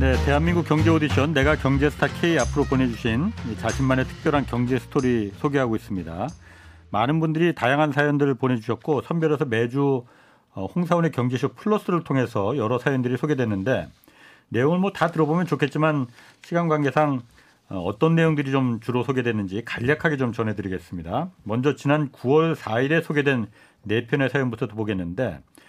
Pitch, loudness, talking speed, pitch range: 130 Hz, -23 LUFS, 365 characters per minute, 115-150 Hz